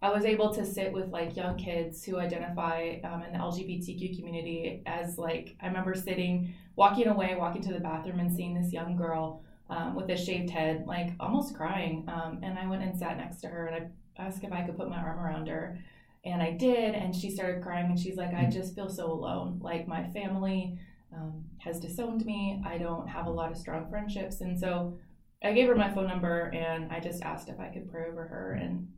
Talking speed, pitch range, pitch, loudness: 225 wpm, 165-190 Hz, 175 Hz, -33 LUFS